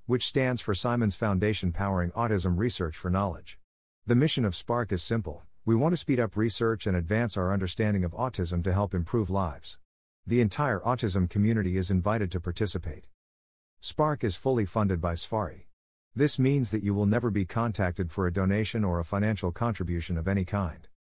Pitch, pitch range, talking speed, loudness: 100 Hz, 90-115 Hz, 180 wpm, -28 LUFS